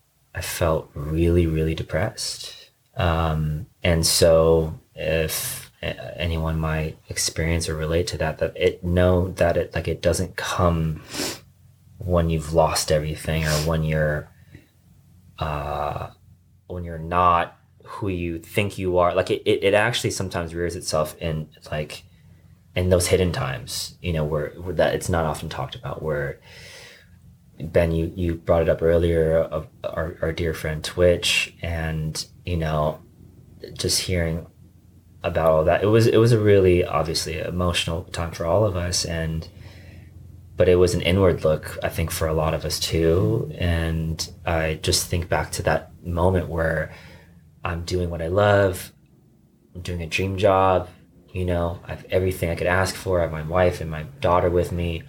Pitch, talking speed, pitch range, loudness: 85 Hz, 165 wpm, 80-90 Hz, -23 LUFS